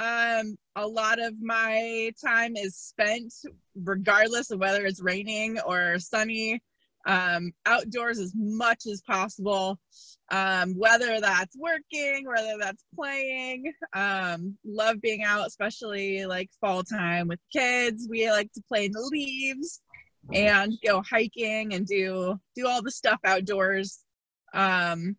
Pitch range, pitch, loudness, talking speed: 195-230 Hz, 215 Hz, -27 LUFS, 135 wpm